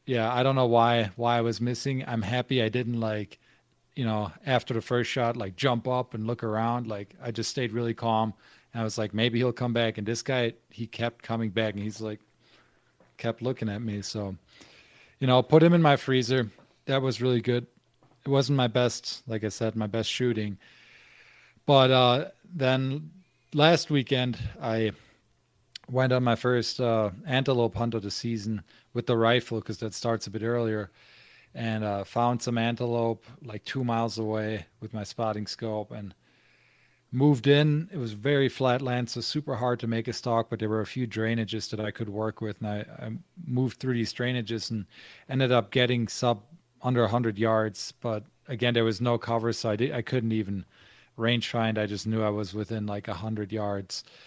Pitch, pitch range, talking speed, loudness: 115 Hz, 110-125 Hz, 200 wpm, -28 LUFS